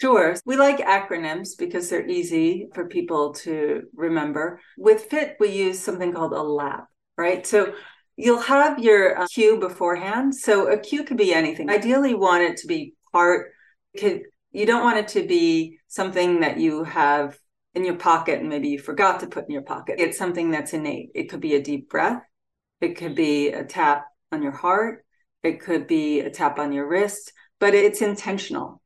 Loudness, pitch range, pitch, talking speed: -22 LUFS, 160-265 Hz, 190 Hz, 190 wpm